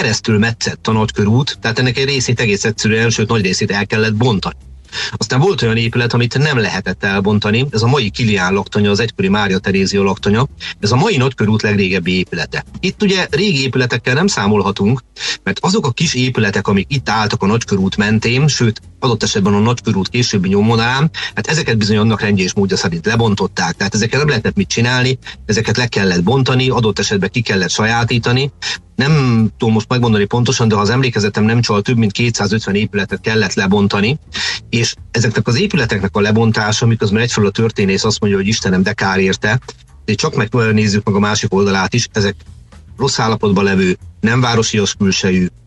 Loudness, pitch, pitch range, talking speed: -14 LUFS, 110 Hz, 100-120 Hz, 180 wpm